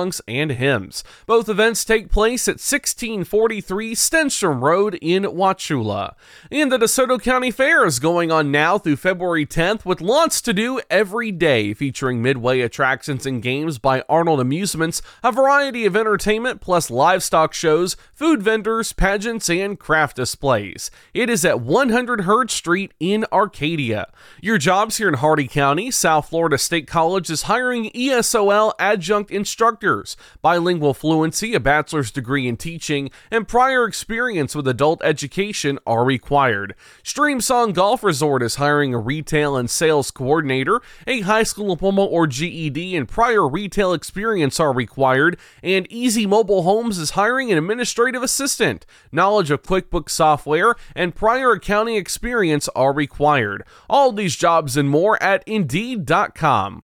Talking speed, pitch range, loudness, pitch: 145 wpm, 150-220 Hz, -18 LUFS, 180 Hz